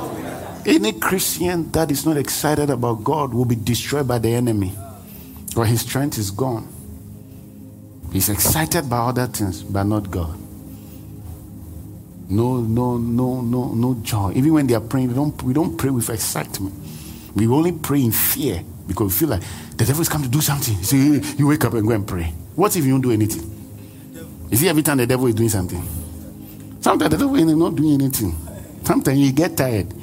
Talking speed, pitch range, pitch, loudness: 190 wpm, 100-140 Hz, 115 Hz, -19 LUFS